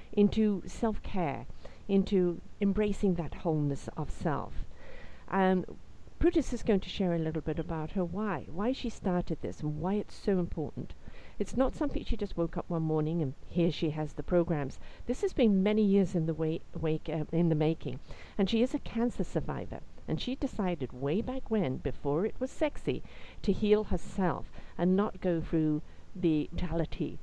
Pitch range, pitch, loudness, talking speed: 160-210 Hz, 180 Hz, -32 LUFS, 185 wpm